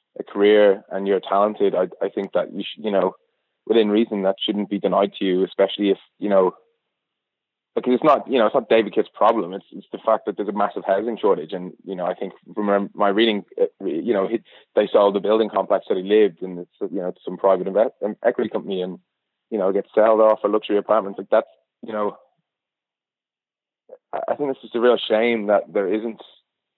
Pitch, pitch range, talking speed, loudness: 105 Hz, 95-110 Hz, 215 wpm, -21 LUFS